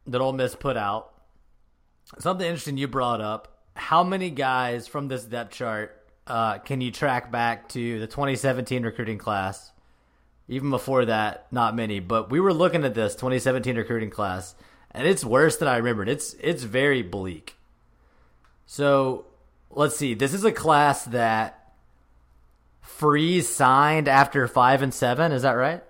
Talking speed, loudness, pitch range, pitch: 160 wpm, -24 LUFS, 110-140 Hz, 125 Hz